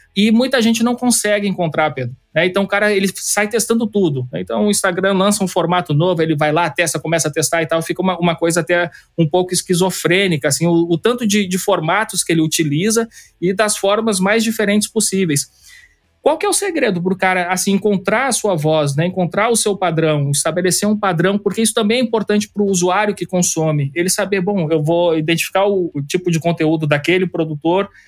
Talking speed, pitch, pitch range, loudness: 200 wpm, 185 Hz, 165-210 Hz, -16 LUFS